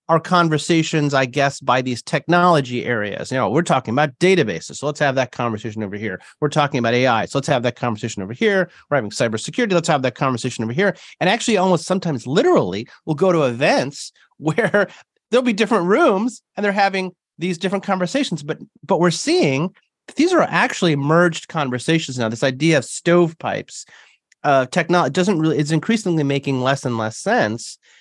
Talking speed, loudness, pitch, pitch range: 180 wpm, -19 LUFS, 160 Hz, 130-185 Hz